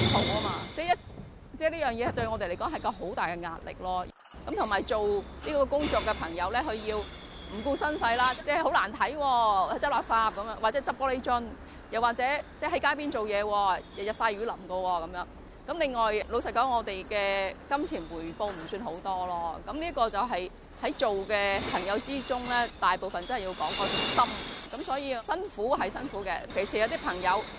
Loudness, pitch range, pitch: -30 LUFS, 195-275 Hz, 225 Hz